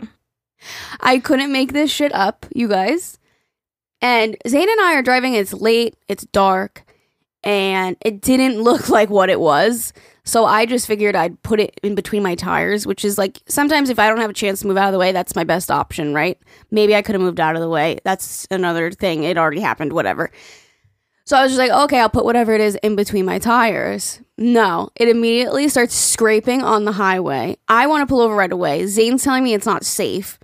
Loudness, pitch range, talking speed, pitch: -16 LUFS, 195-245 Hz, 215 wpm, 215 Hz